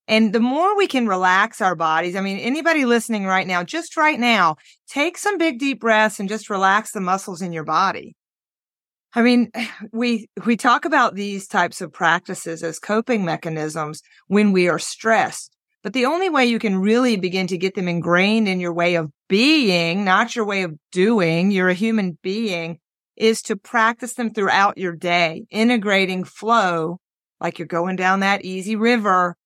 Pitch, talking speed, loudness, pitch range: 200 Hz, 180 wpm, -19 LUFS, 180-235 Hz